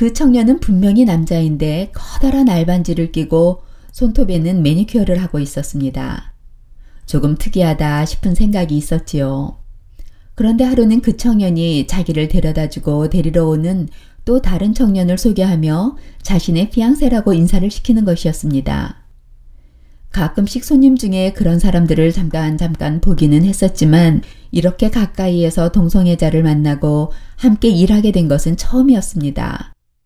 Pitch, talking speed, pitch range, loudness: 175 Hz, 320 characters per minute, 155-205 Hz, -14 LUFS